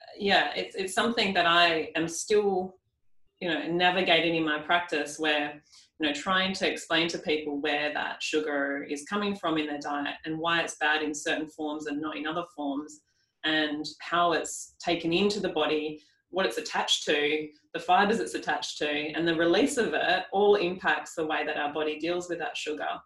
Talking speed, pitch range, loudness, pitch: 195 wpm, 150-175 Hz, -28 LUFS, 155 Hz